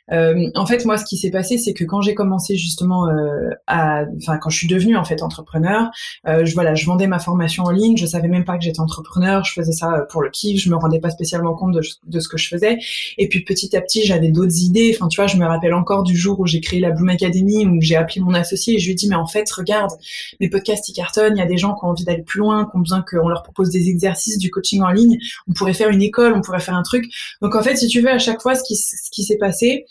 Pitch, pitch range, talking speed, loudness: 185 Hz, 170-210 Hz, 295 wpm, -17 LUFS